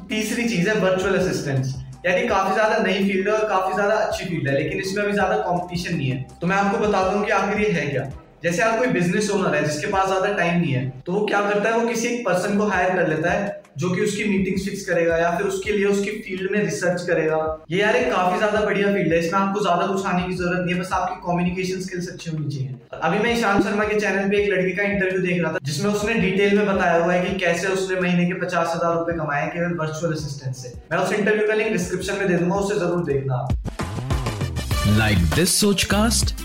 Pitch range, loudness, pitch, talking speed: 170-200 Hz, -21 LUFS, 185 Hz, 185 wpm